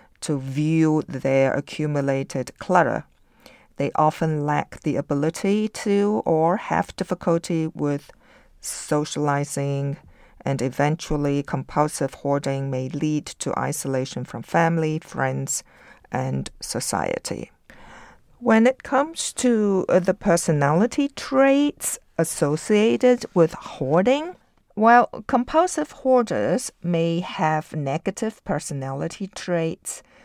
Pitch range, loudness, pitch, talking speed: 140-200 Hz, -23 LUFS, 160 Hz, 95 wpm